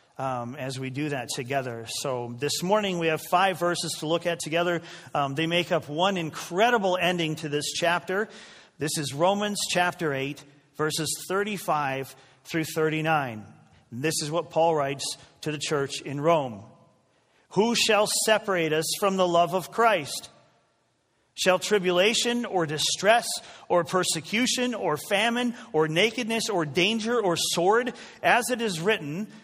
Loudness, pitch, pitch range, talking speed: -25 LUFS, 170 Hz, 150-200 Hz, 150 wpm